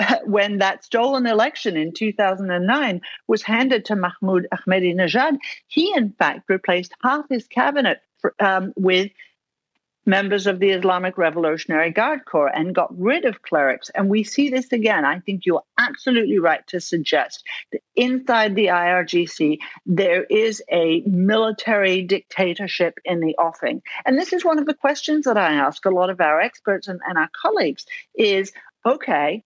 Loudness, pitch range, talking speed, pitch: -20 LUFS, 185-250 Hz, 160 wpm, 200 Hz